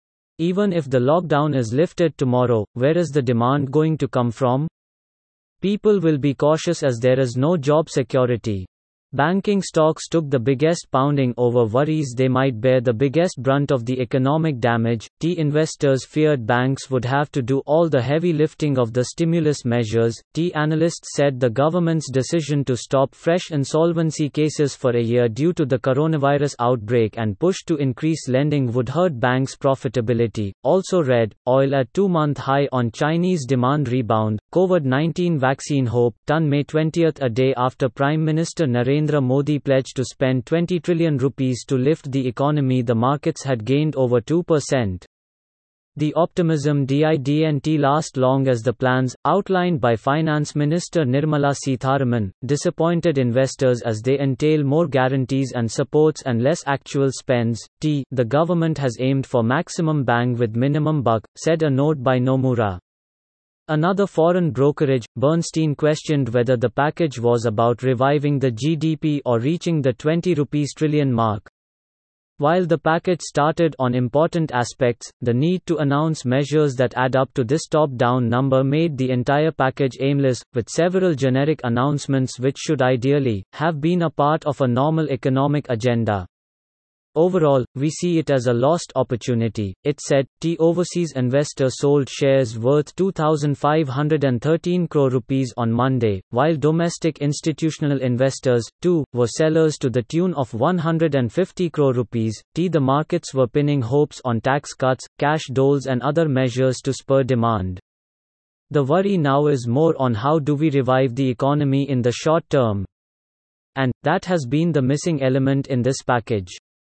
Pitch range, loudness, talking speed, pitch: 125-155 Hz, -20 LUFS, 160 wpm, 140 Hz